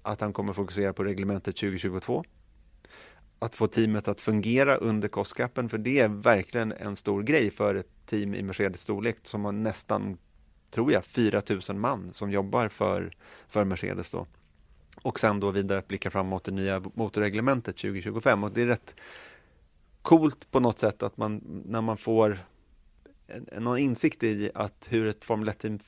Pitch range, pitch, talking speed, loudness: 95-115 Hz, 105 Hz, 170 wpm, -28 LUFS